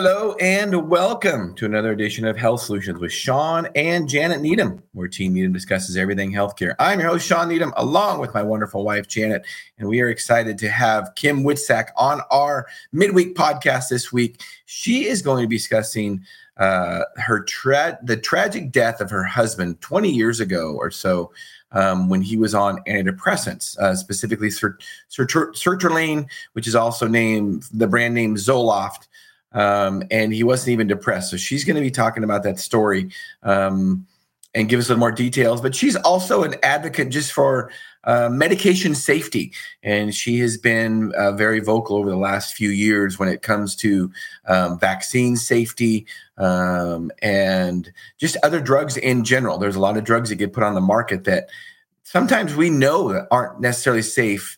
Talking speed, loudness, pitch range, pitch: 180 wpm, -19 LUFS, 100-140 Hz, 115 Hz